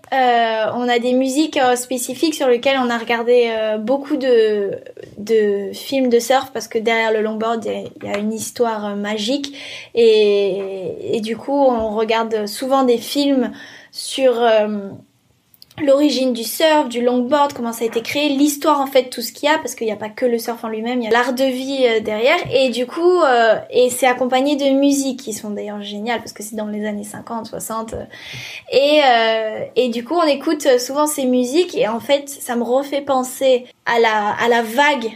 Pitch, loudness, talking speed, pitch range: 245 Hz, -17 LUFS, 205 wpm, 225-275 Hz